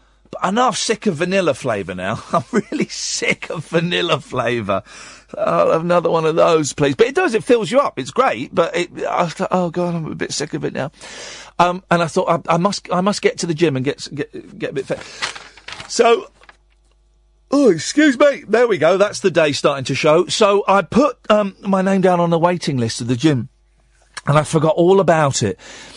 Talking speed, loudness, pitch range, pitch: 220 wpm, -17 LUFS, 150-205 Hz, 175 Hz